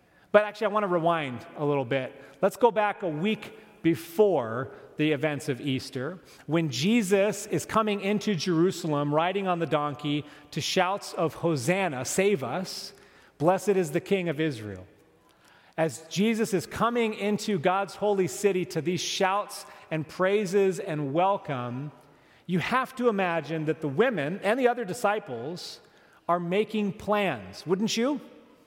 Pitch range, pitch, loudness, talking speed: 155-205 Hz, 185 Hz, -27 LUFS, 150 wpm